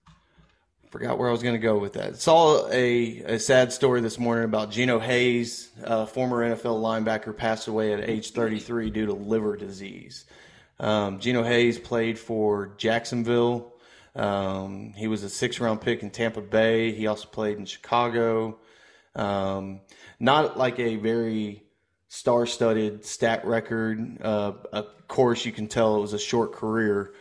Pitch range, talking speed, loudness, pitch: 105-120 Hz, 155 wpm, -25 LUFS, 110 Hz